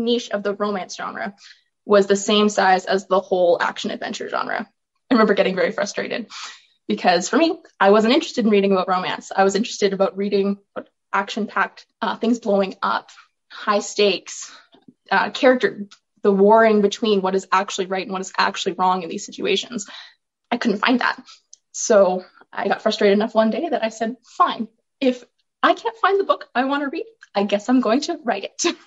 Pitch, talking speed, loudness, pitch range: 210 Hz, 190 wpm, -20 LUFS, 195-245 Hz